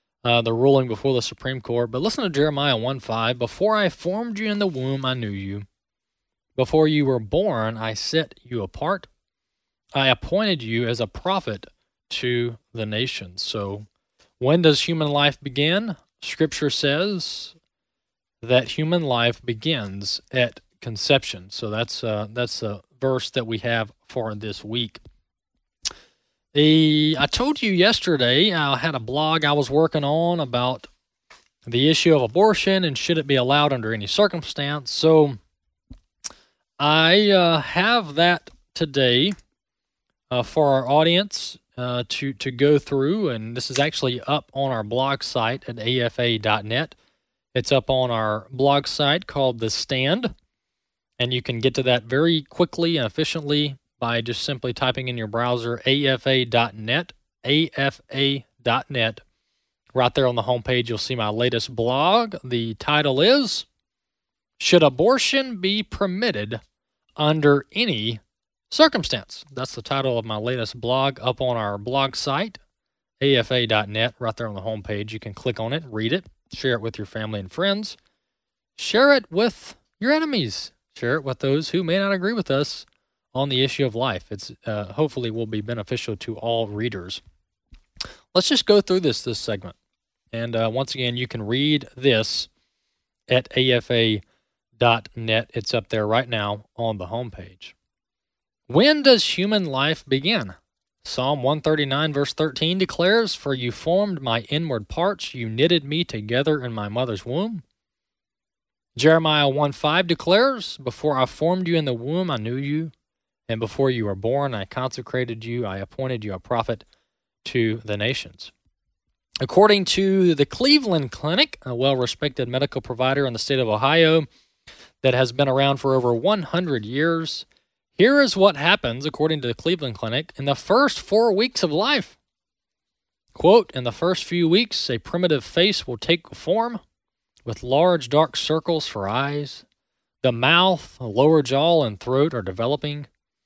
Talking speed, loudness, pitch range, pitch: 155 wpm, -21 LUFS, 115-160 Hz, 130 Hz